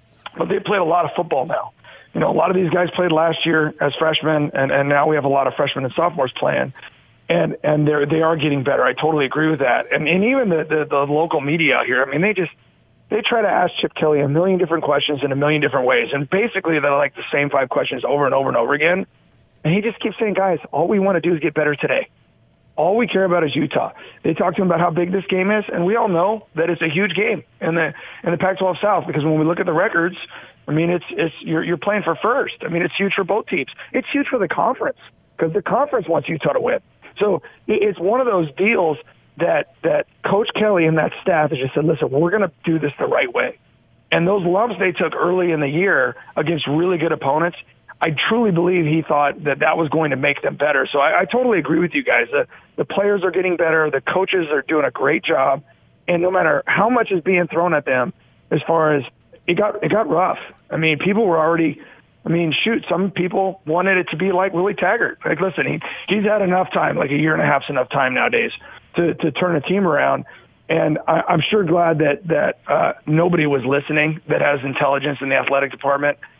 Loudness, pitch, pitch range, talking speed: -18 LUFS, 165 Hz, 150-185 Hz, 245 wpm